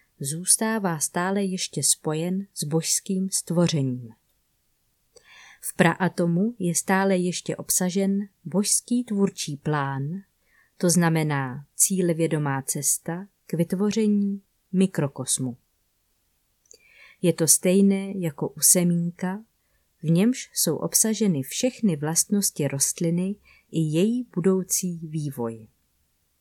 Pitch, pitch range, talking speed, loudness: 175 Hz, 155-195 Hz, 95 wpm, -23 LUFS